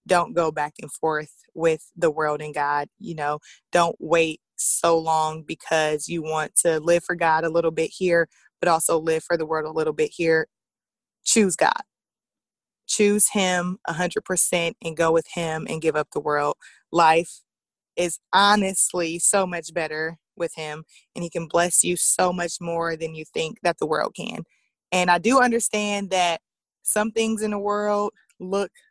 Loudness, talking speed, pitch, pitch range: -22 LUFS, 175 wpm, 170 Hz, 160-185 Hz